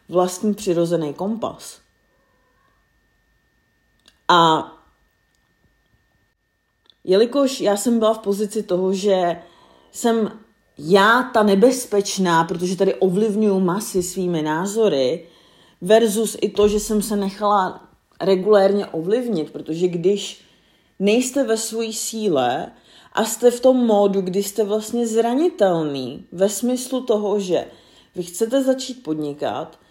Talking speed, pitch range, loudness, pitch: 110 wpm, 180-225 Hz, -19 LUFS, 200 Hz